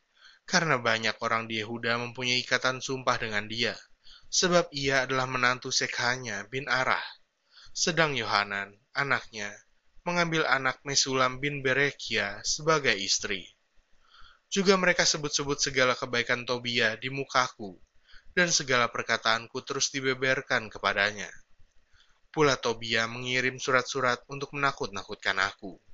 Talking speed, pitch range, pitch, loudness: 110 wpm, 115-140 Hz, 130 Hz, -27 LUFS